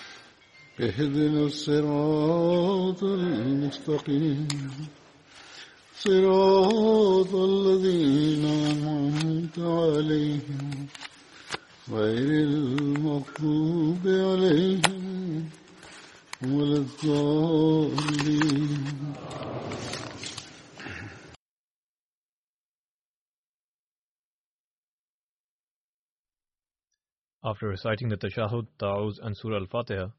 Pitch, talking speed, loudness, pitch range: 150 Hz, 40 wpm, -25 LUFS, 140-165 Hz